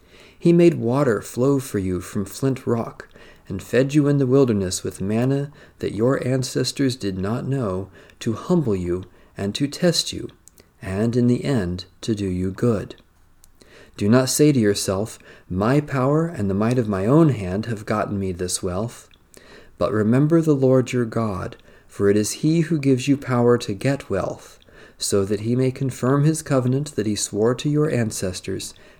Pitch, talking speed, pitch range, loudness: 120 Hz, 180 wpm, 100-135 Hz, -21 LUFS